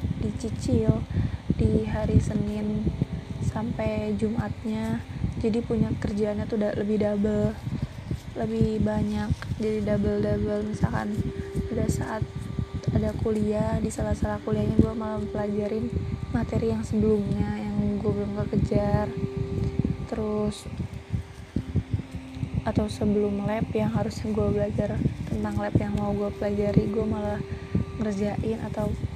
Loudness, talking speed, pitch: -27 LUFS, 115 wpm, 110 Hz